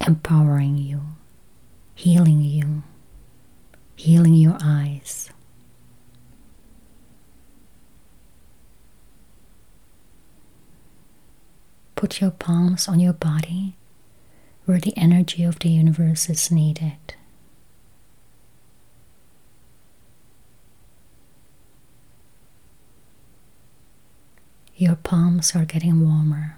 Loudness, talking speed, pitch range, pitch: -19 LUFS, 60 wpm, 145-170 Hz, 160 Hz